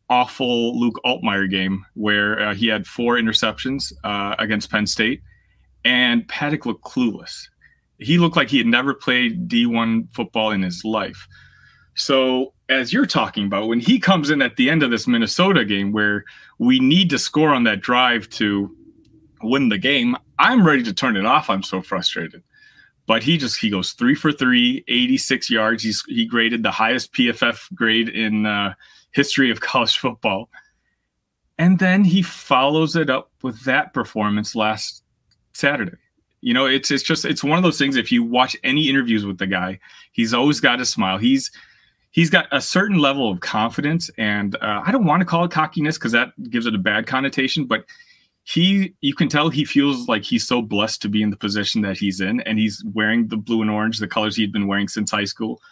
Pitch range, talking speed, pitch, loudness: 110-170 Hz, 195 wpm, 125 Hz, -19 LUFS